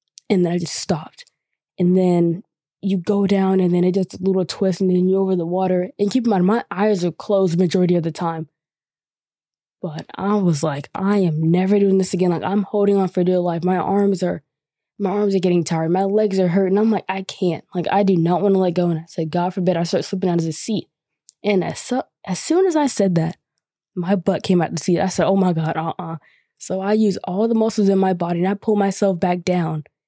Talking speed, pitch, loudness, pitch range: 250 wpm, 185 Hz, -19 LUFS, 175-200 Hz